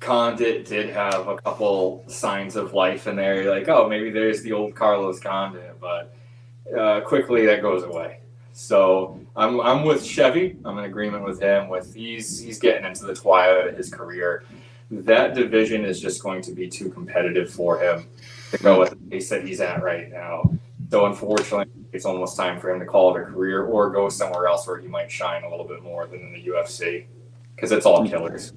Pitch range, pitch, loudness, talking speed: 95-120 Hz, 105 Hz, -22 LUFS, 205 wpm